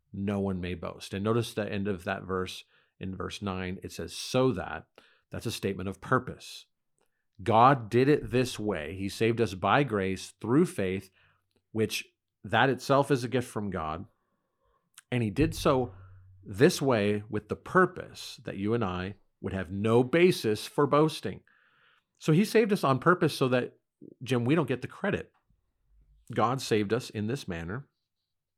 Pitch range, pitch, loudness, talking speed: 95-130 Hz, 110 Hz, -29 LUFS, 170 wpm